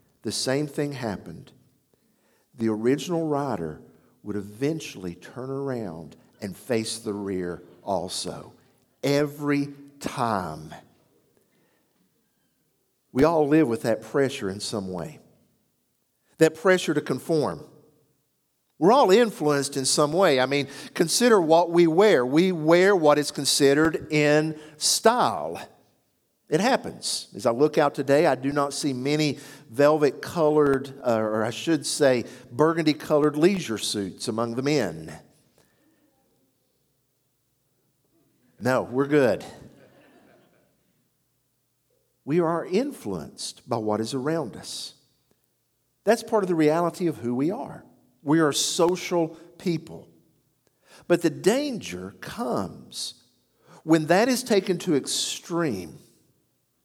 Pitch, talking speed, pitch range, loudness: 145 Hz, 115 wpm, 125-160 Hz, -24 LUFS